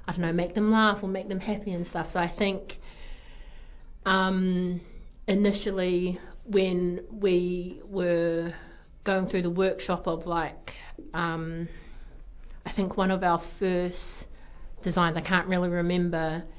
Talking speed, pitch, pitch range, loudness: 135 wpm, 180 Hz, 175-190 Hz, -28 LUFS